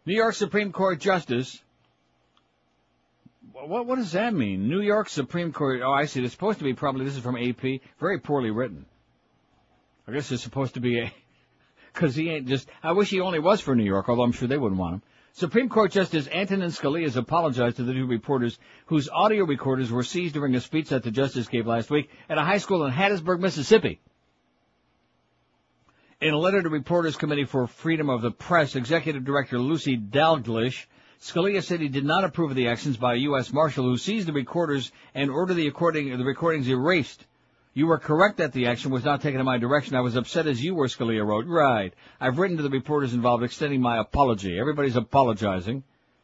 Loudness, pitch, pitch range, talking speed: -25 LUFS, 140 Hz, 125-170 Hz, 205 wpm